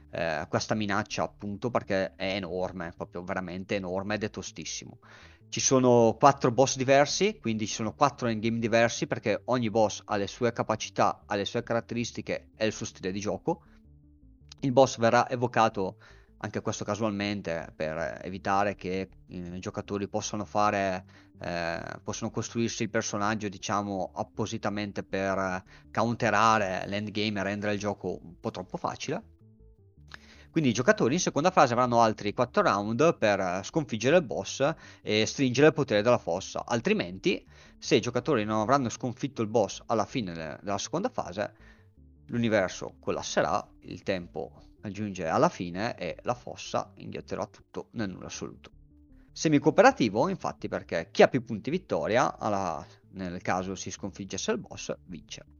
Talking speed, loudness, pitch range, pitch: 150 wpm, -28 LUFS, 95-115 Hz, 105 Hz